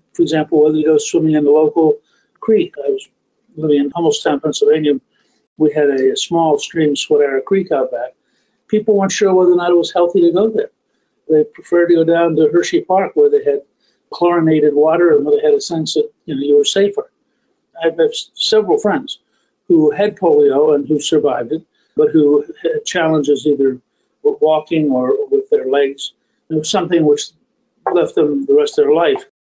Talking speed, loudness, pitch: 195 wpm, -14 LUFS, 170 Hz